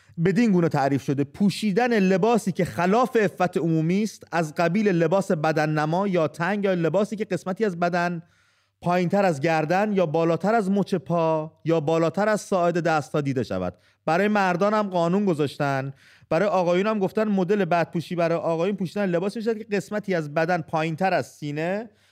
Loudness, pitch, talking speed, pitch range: -23 LUFS, 180 Hz, 175 wpm, 160-200 Hz